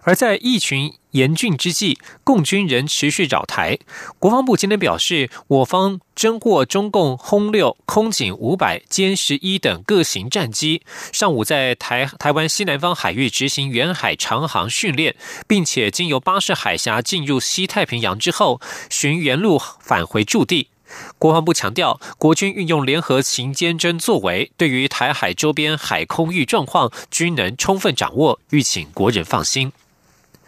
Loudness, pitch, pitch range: -18 LUFS, 165 Hz, 140-190 Hz